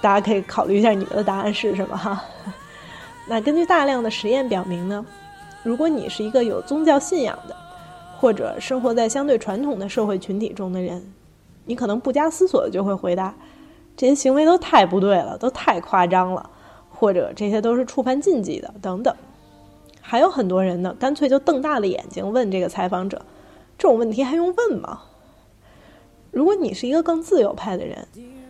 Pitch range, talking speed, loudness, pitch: 195-285 Hz, 285 characters per minute, -21 LUFS, 230 Hz